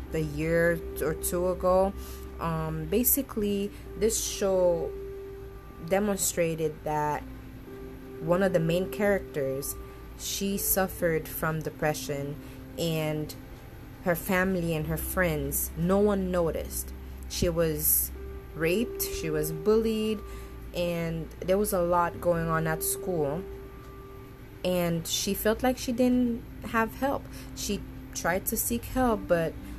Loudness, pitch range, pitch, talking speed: -28 LUFS, 130-195 Hz, 165 Hz, 115 wpm